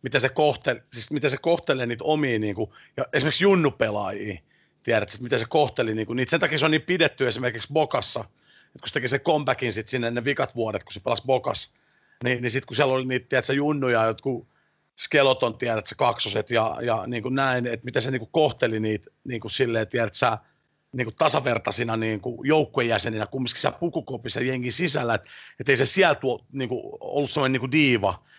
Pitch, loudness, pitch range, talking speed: 130 Hz, -24 LUFS, 120-145 Hz, 185 wpm